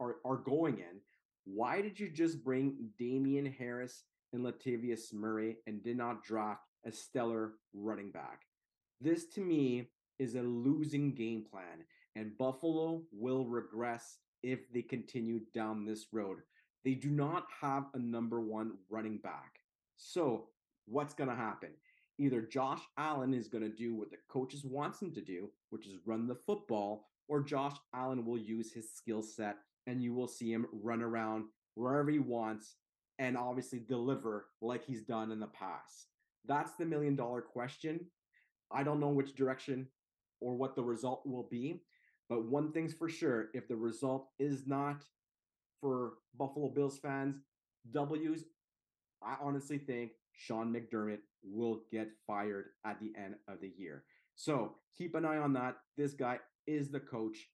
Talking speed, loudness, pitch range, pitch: 160 wpm, -40 LUFS, 110-140 Hz, 125 Hz